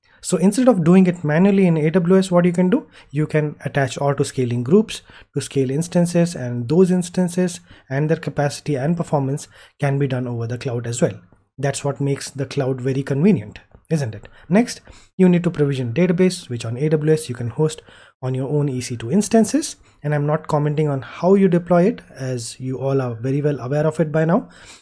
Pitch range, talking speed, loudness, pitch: 135-175 Hz, 200 wpm, -19 LUFS, 150 Hz